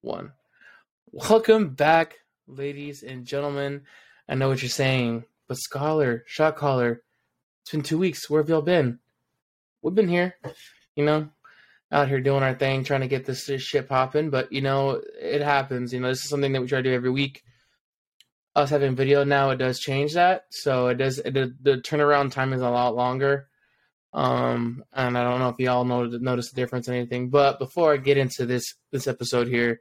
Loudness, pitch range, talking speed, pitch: -24 LUFS, 125-145 Hz, 195 wpm, 135 Hz